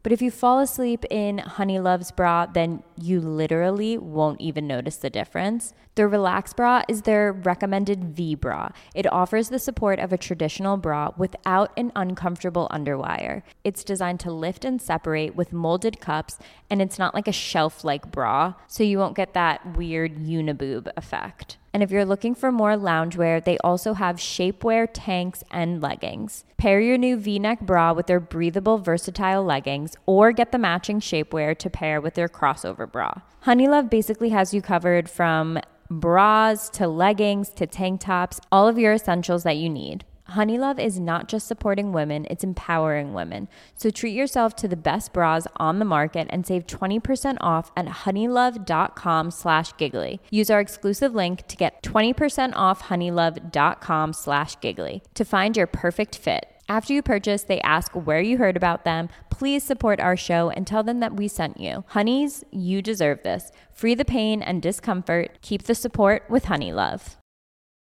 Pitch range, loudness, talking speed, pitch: 165-215 Hz, -23 LUFS, 165 wpm, 185 Hz